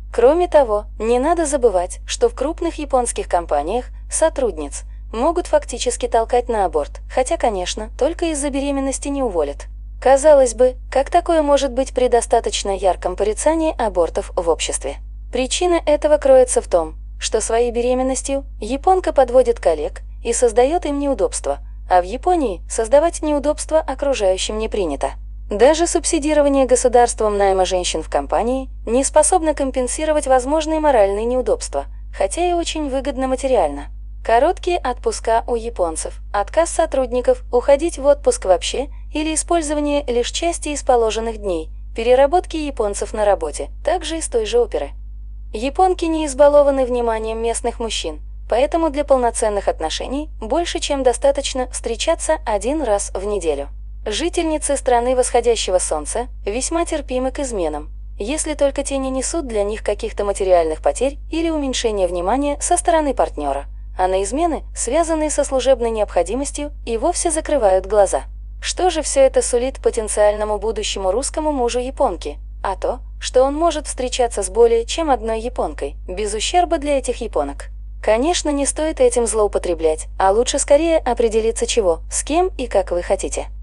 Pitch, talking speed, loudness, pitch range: 265 Hz, 140 wpm, -18 LUFS, 230-315 Hz